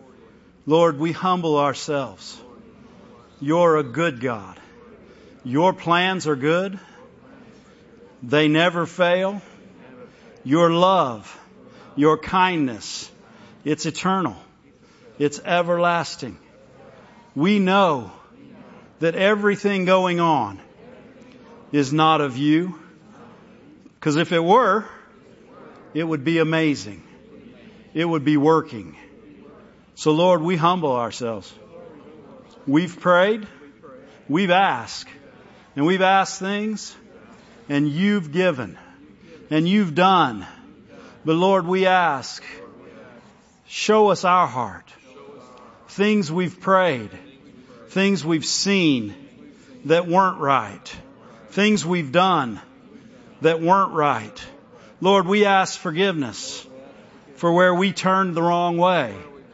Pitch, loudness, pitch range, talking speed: 170 Hz, -20 LUFS, 150-190 Hz, 100 wpm